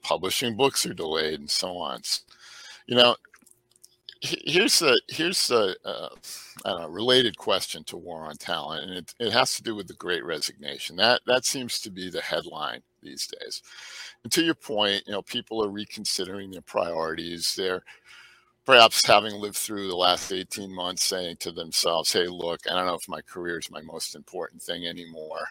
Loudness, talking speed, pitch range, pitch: -25 LUFS, 180 wpm, 90-120 Hz, 100 Hz